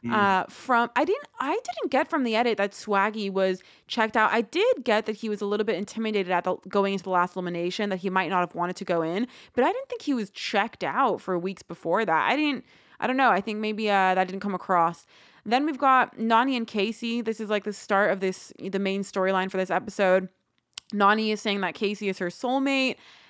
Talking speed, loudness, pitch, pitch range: 240 wpm, -26 LUFS, 205 Hz, 190-225 Hz